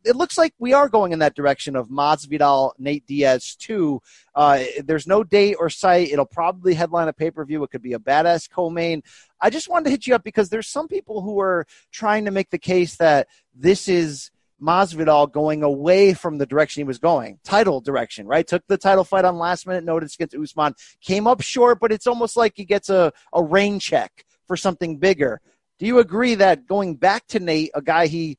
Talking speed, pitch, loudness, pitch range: 215 wpm, 175 Hz, -19 LUFS, 155-205 Hz